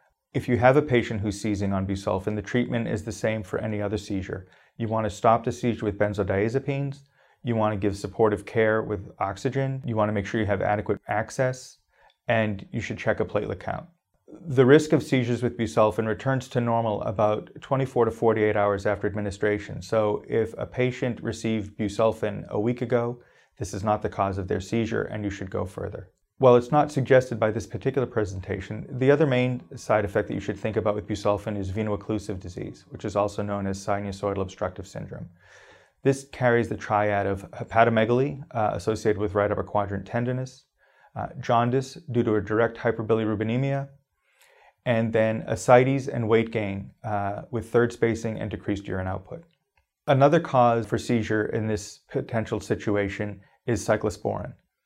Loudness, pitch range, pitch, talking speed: -25 LUFS, 105-125 Hz, 110 Hz, 180 wpm